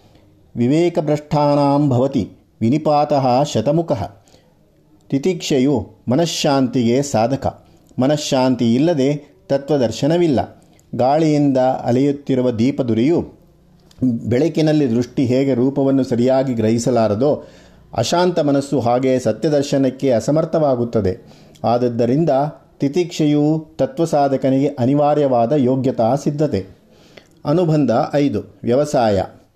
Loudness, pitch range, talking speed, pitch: -17 LUFS, 125-150 Hz, 65 wpm, 135 Hz